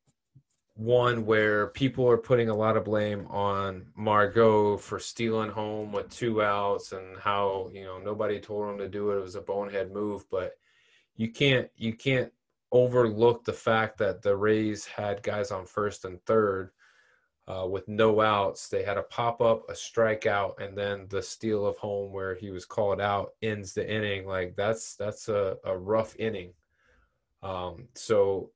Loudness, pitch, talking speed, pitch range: -28 LUFS, 105 Hz, 170 wpm, 100-115 Hz